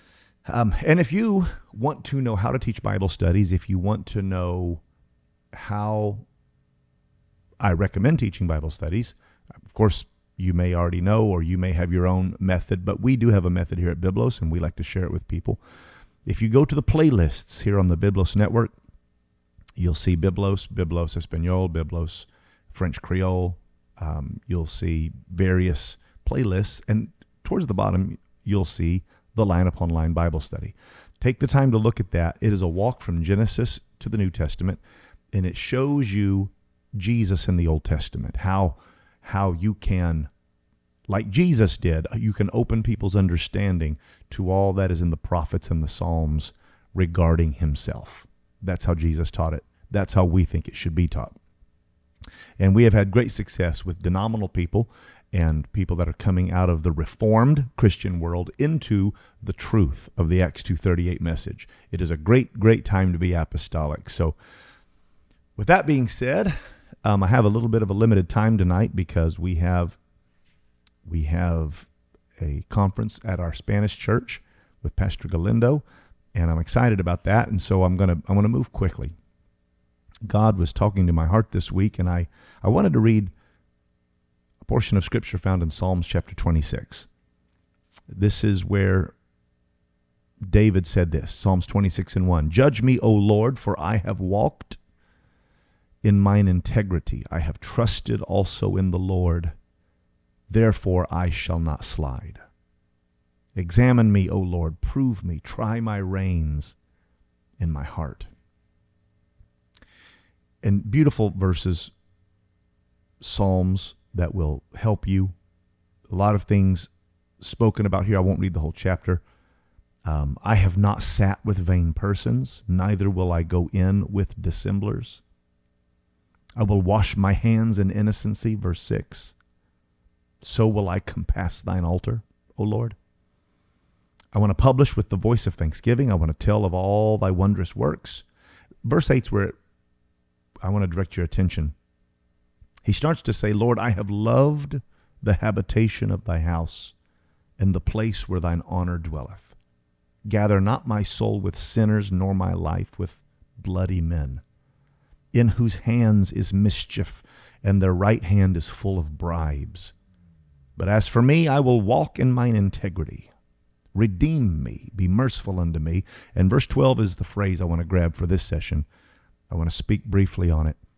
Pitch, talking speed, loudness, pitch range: 95 Hz, 160 wpm, -23 LUFS, 85-105 Hz